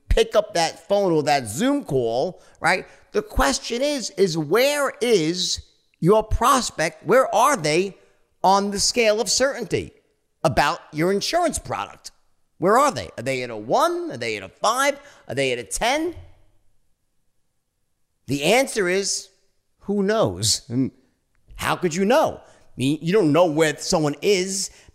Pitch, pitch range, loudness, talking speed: 180 Hz, 140-215 Hz, -21 LUFS, 155 wpm